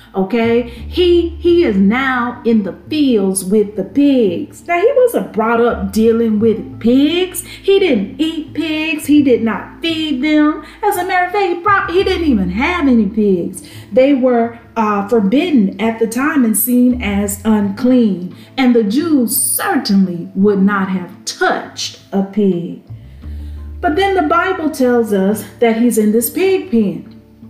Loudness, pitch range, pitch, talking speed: -14 LUFS, 205-305 Hz, 235 Hz, 160 wpm